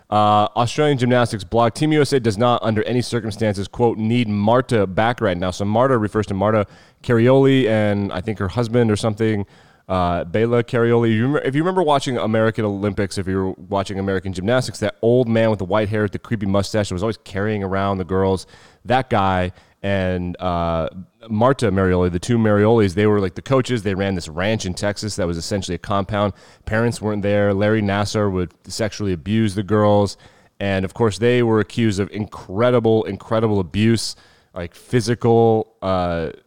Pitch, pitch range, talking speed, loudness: 105 Hz, 95-115 Hz, 180 wpm, -19 LUFS